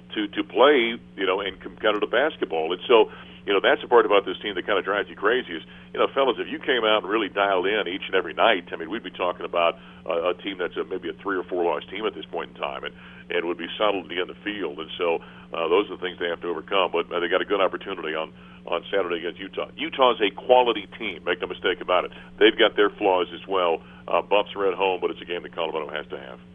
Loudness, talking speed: -24 LUFS, 275 wpm